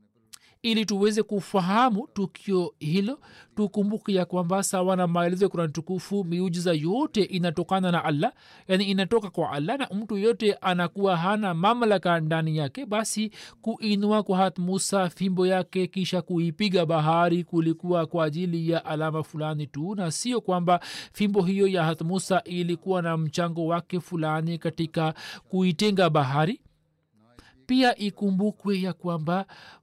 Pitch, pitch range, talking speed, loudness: 185 Hz, 165-200 Hz, 135 wpm, -26 LUFS